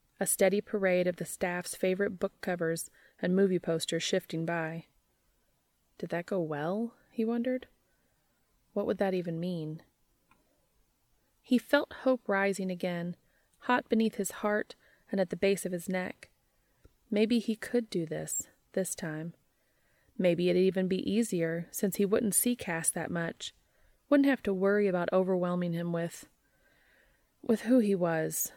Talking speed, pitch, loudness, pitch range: 150 wpm, 190 Hz, -31 LUFS, 170-215 Hz